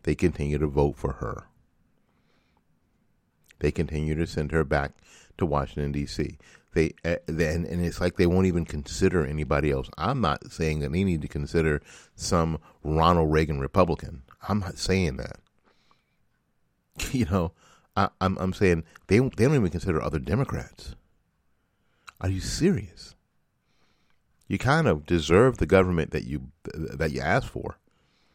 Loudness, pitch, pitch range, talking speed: -26 LUFS, 80 Hz, 75-95 Hz, 150 wpm